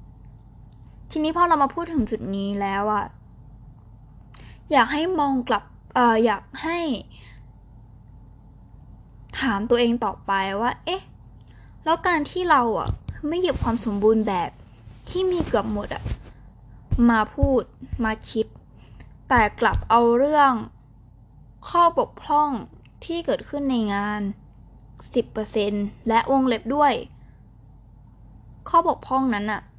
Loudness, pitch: -23 LUFS, 215 Hz